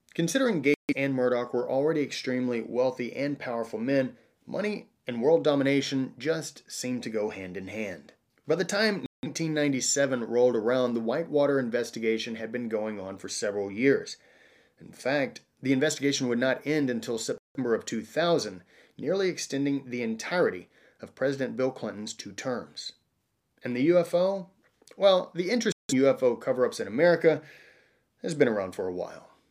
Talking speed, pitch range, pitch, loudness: 155 wpm, 120-160 Hz, 135 Hz, -28 LUFS